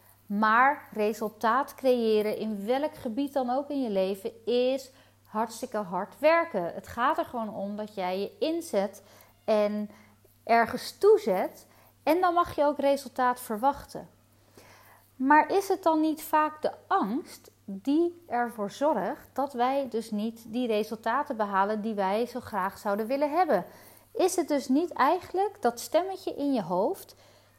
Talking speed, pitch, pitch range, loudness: 150 wpm, 245 Hz, 210-295 Hz, -28 LUFS